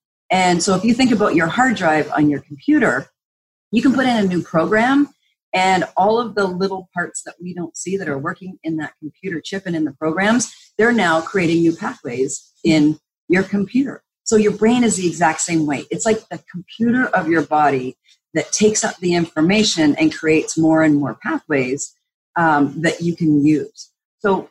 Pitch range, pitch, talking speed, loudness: 155-215 Hz, 175 Hz, 195 wpm, -18 LUFS